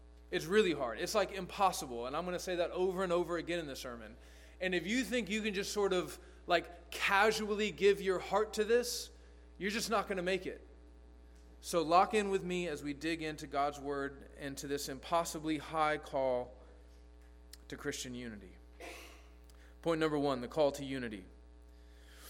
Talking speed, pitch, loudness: 185 wpm, 155 Hz, -35 LUFS